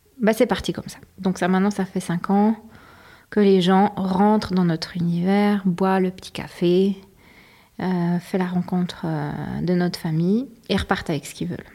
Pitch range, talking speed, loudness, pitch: 180-205 Hz, 185 wpm, -22 LUFS, 190 Hz